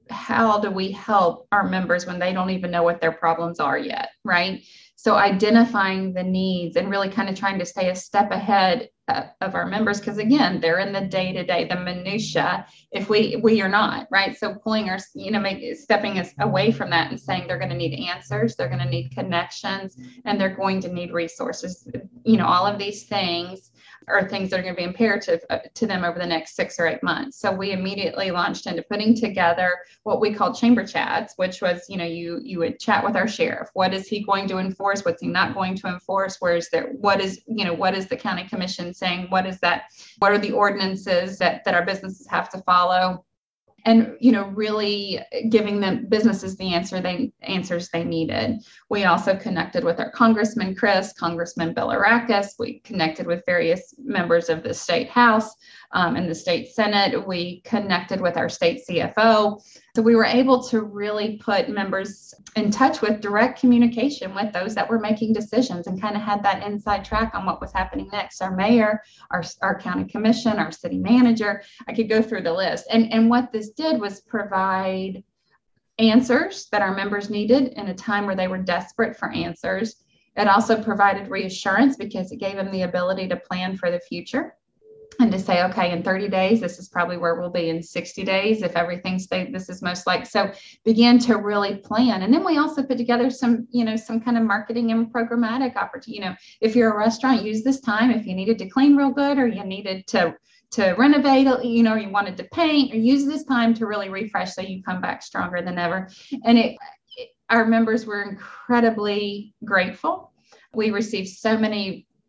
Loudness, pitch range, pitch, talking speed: -22 LUFS, 185-230 Hz, 200 Hz, 205 wpm